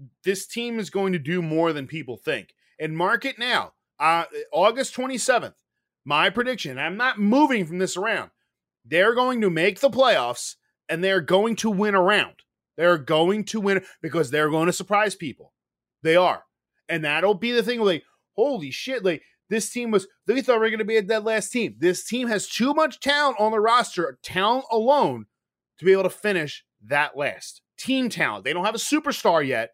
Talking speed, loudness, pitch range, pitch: 200 wpm, -23 LUFS, 165-235 Hz, 200 Hz